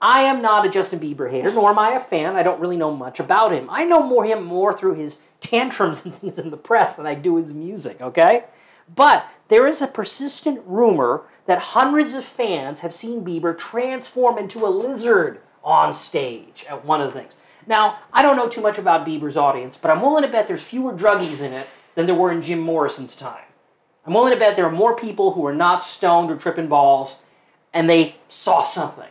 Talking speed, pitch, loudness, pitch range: 220 wpm, 190 Hz, -18 LUFS, 165-240 Hz